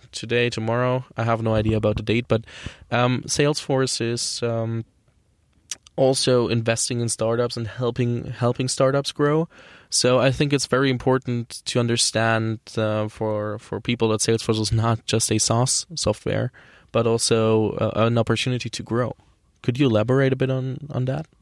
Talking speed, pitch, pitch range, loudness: 160 wpm, 120 Hz, 110-130 Hz, -22 LUFS